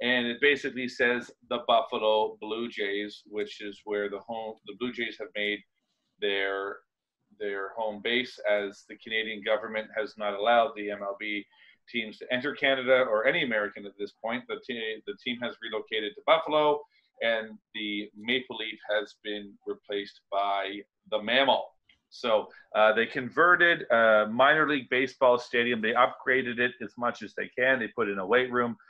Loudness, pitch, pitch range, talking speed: -28 LUFS, 110 Hz, 105-125 Hz, 170 wpm